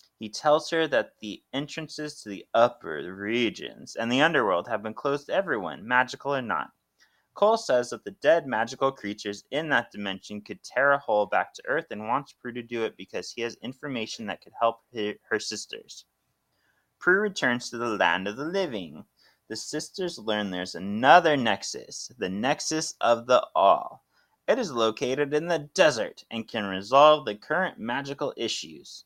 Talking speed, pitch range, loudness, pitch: 175 wpm, 105-145 Hz, -26 LUFS, 120 Hz